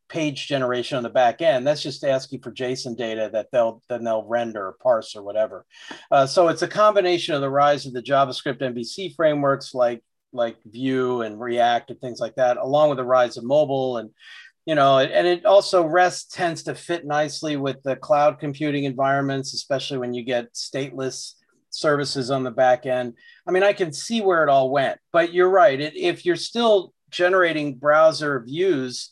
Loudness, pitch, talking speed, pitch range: -21 LUFS, 140 Hz, 190 wpm, 125-160 Hz